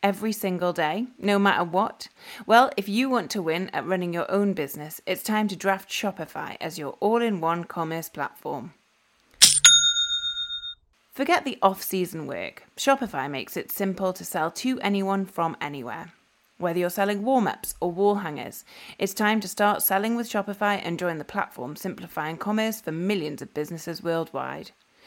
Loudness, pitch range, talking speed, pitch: -24 LUFS, 170-215 Hz, 170 wpm, 195 Hz